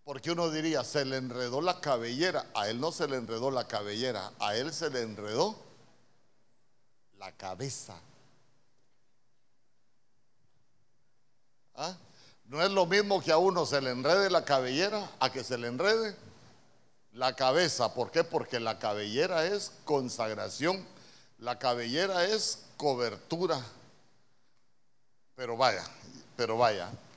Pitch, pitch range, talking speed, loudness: 130 Hz, 120-160 Hz, 130 wpm, -31 LUFS